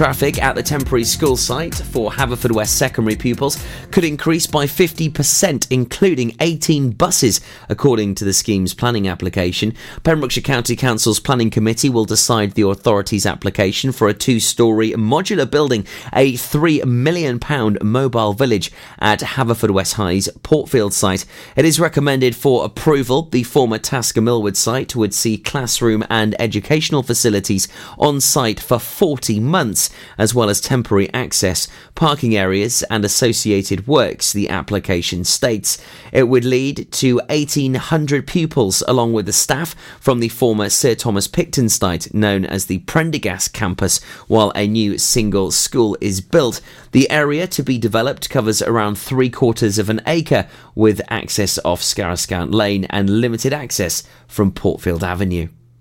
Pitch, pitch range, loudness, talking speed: 115 Hz, 105-135 Hz, -16 LUFS, 145 wpm